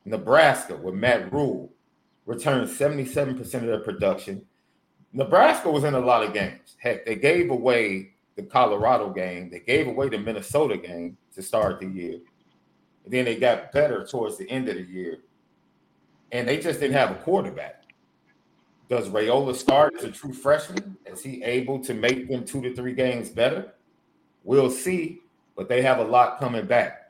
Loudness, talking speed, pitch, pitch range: -24 LUFS, 175 wpm, 125 Hz, 115-135 Hz